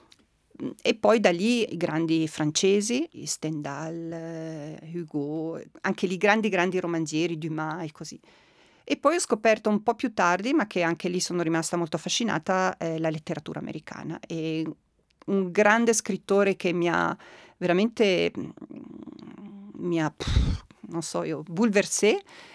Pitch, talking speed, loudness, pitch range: 175 Hz, 140 wpm, -26 LUFS, 160-210 Hz